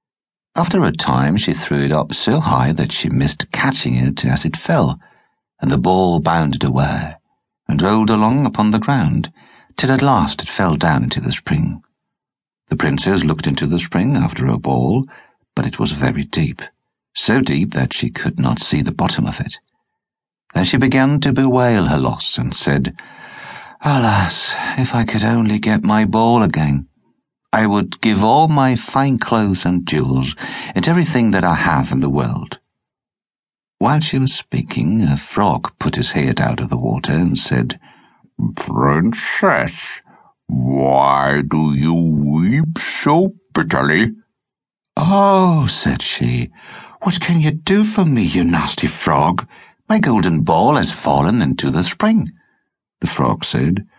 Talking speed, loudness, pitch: 160 wpm, -16 LUFS, 110 Hz